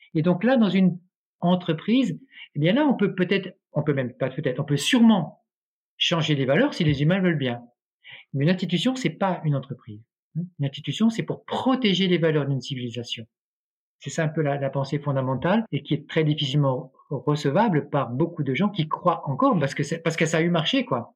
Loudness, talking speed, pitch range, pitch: -24 LUFS, 215 wpm, 140-185 Hz, 160 Hz